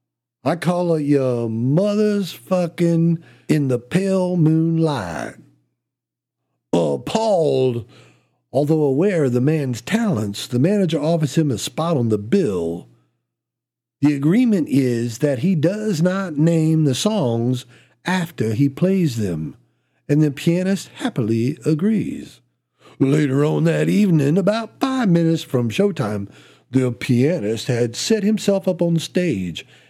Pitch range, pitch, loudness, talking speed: 120-175 Hz, 150 Hz, -19 LUFS, 125 wpm